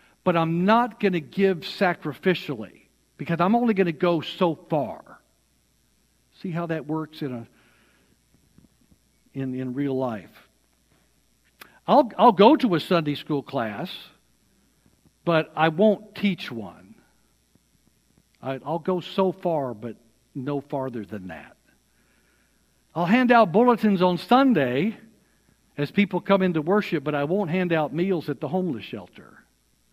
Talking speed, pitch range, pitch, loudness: 140 wpm, 135-195 Hz, 165 Hz, -23 LUFS